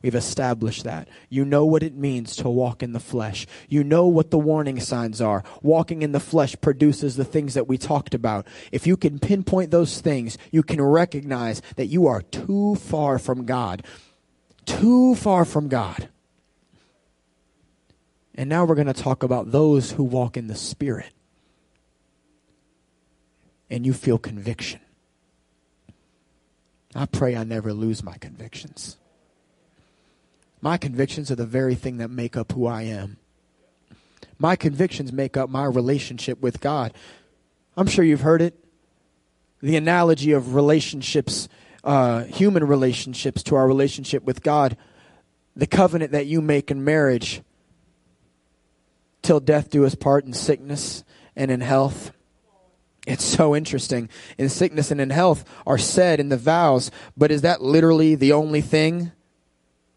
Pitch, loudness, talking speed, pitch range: 130 Hz, -21 LUFS, 150 wpm, 105-150 Hz